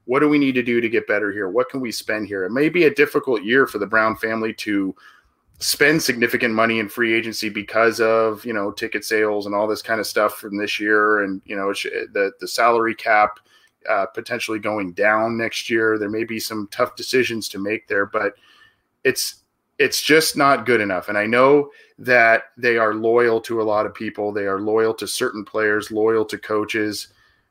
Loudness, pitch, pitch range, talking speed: -19 LUFS, 110 Hz, 105-120 Hz, 210 wpm